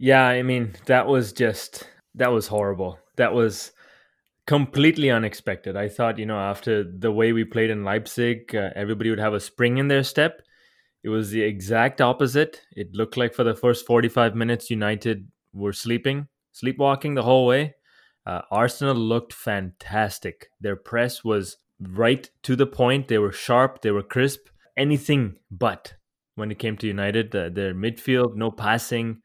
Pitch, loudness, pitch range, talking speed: 115 Hz, -23 LUFS, 105-130 Hz, 170 wpm